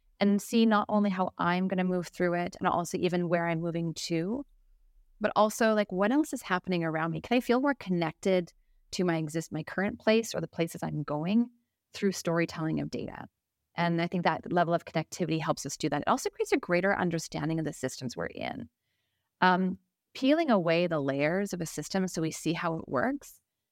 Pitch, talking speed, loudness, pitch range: 180 Hz, 210 wpm, -30 LUFS, 165-205 Hz